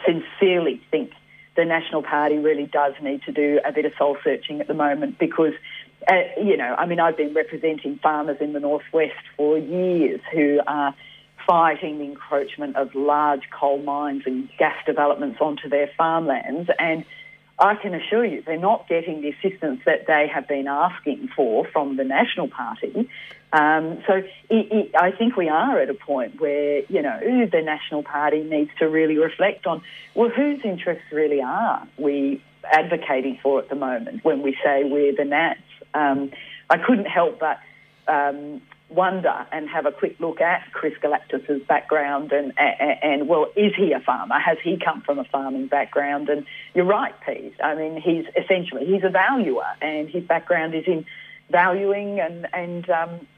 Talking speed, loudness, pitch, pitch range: 180 wpm, -22 LUFS, 155 Hz, 145-175 Hz